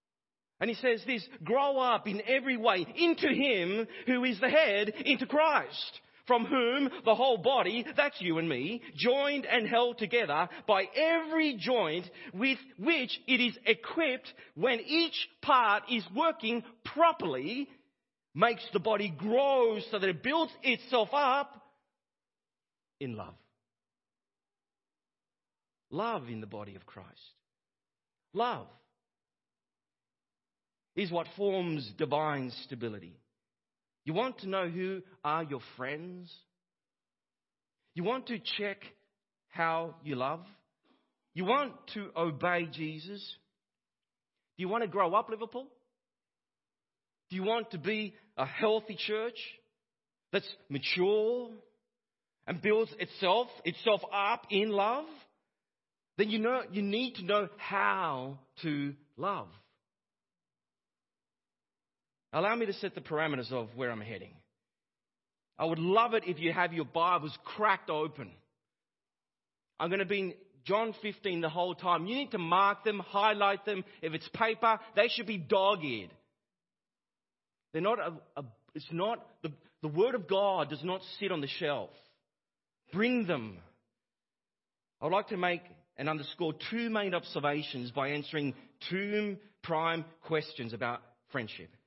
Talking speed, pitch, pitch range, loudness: 130 wpm, 205 Hz, 165-235 Hz, -32 LUFS